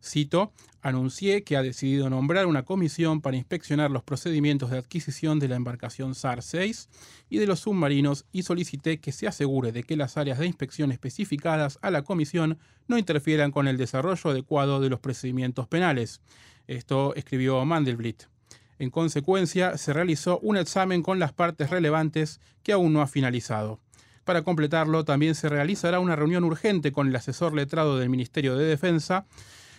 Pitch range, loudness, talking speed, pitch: 130-170 Hz, -26 LUFS, 165 wpm, 150 Hz